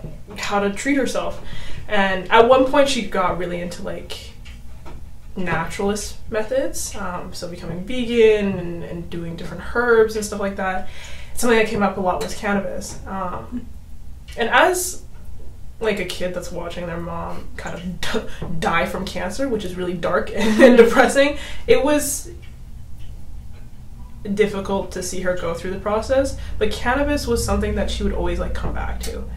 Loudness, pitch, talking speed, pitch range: -20 LUFS, 200 Hz, 165 wpm, 180-235 Hz